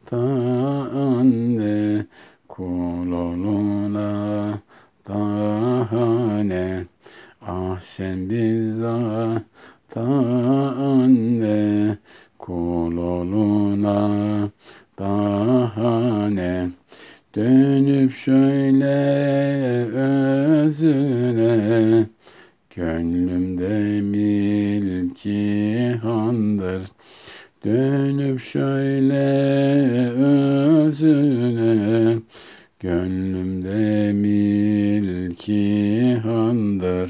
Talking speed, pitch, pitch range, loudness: 35 wpm, 110 Hz, 100-130 Hz, -20 LUFS